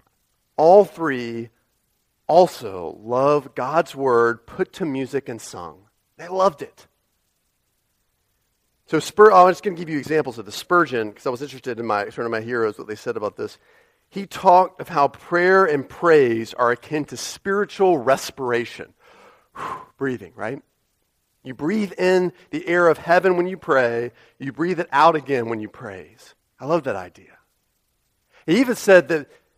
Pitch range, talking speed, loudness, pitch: 120-185 Hz, 165 wpm, -20 LUFS, 150 Hz